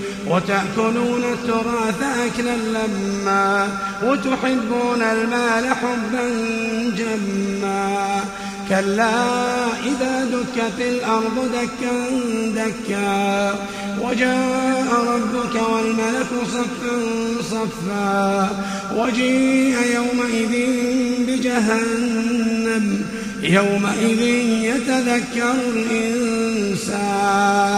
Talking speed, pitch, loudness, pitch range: 55 wpm, 230 Hz, -20 LUFS, 200-245 Hz